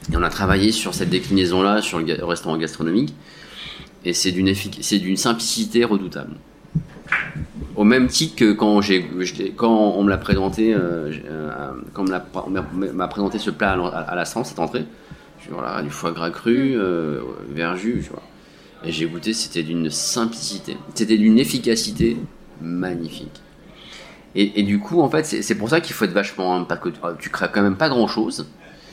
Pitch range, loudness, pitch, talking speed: 85-105 Hz, -21 LUFS, 95 Hz, 160 wpm